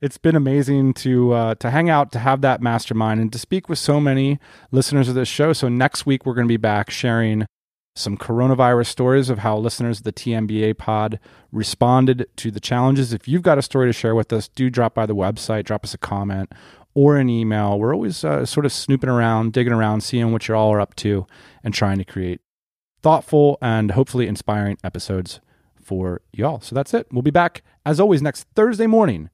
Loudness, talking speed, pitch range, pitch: -19 LUFS, 210 wpm, 110-135 Hz, 120 Hz